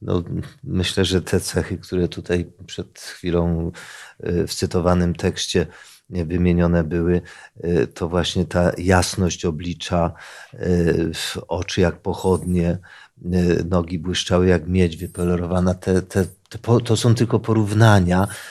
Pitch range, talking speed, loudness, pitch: 85-95 Hz, 105 wpm, -20 LUFS, 90 Hz